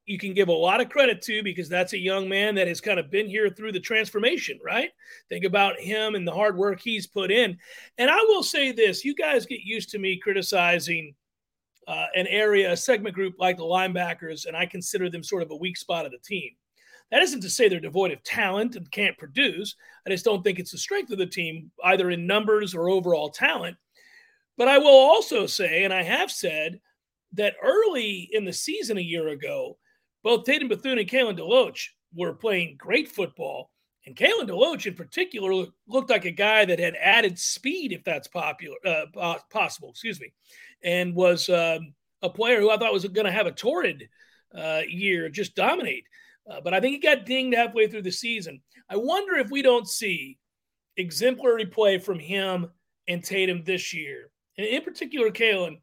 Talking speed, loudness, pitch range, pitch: 200 wpm, -24 LUFS, 180-245 Hz, 205 Hz